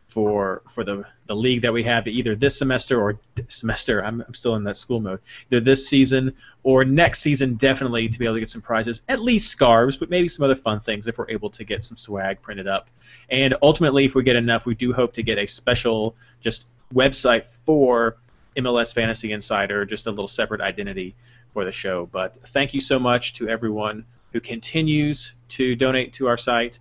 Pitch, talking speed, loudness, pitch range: 120 Hz, 210 wpm, -21 LUFS, 110-130 Hz